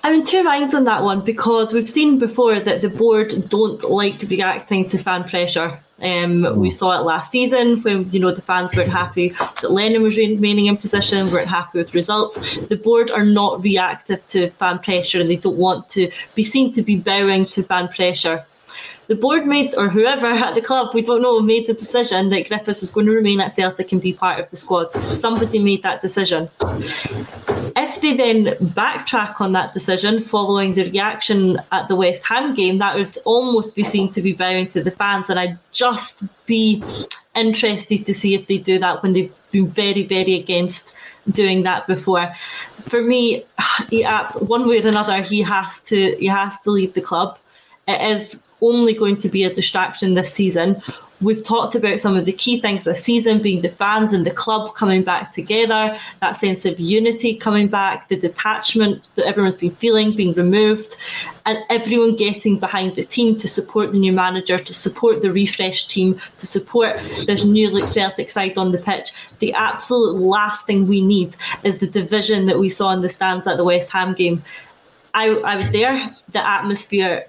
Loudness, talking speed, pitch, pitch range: -17 LUFS, 195 wpm, 200 Hz, 185-220 Hz